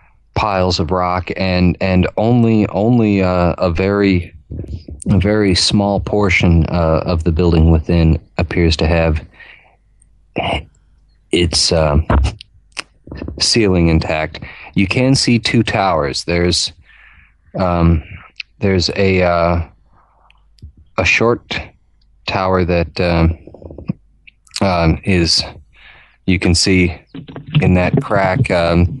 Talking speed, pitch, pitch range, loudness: 105 wpm, 90 Hz, 85-100 Hz, -15 LUFS